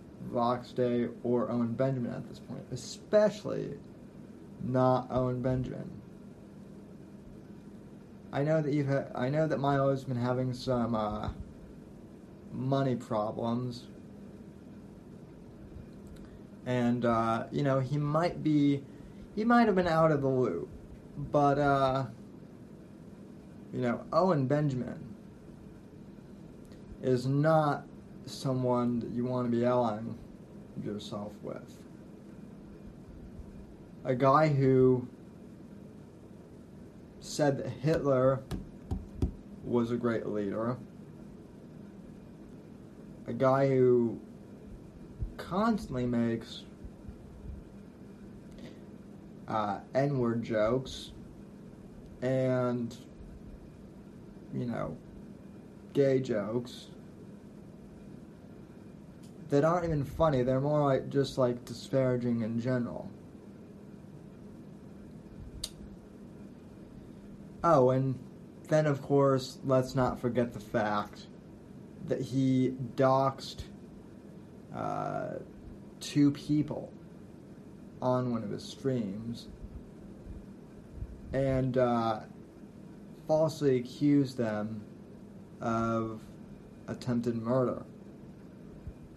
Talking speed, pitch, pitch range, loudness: 85 wpm, 130 Hz, 120-140 Hz, -31 LUFS